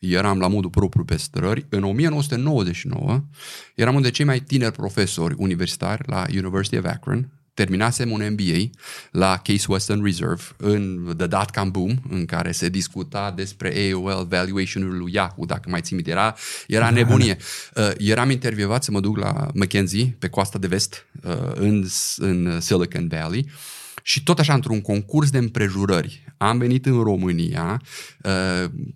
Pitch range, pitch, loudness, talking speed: 95-125 Hz, 100 Hz, -22 LUFS, 160 wpm